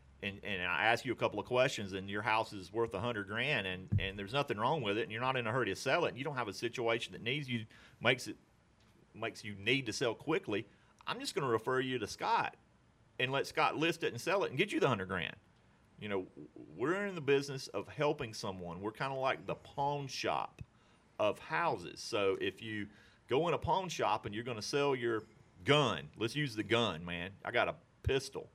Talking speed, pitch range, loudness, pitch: 240 wpm, 100-135 Hz, -36 LUFS, 115 Hz